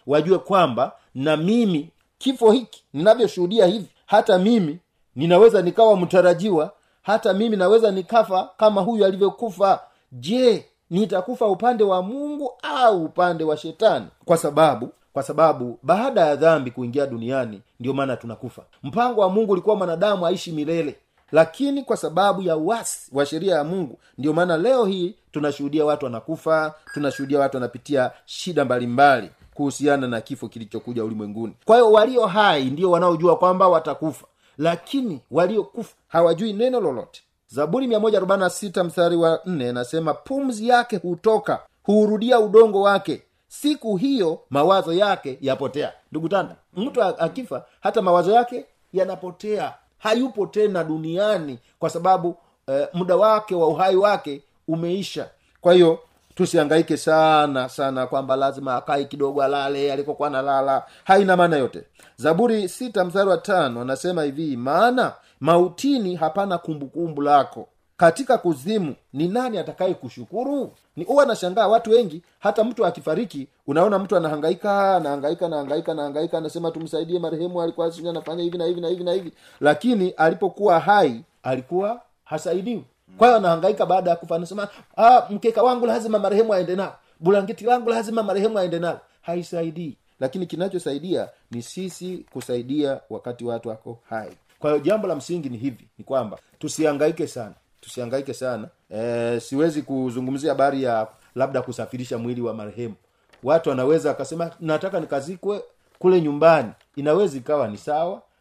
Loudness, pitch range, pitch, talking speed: -21 LUFS, 145-200 Hz, 170 Hz, 135 wpm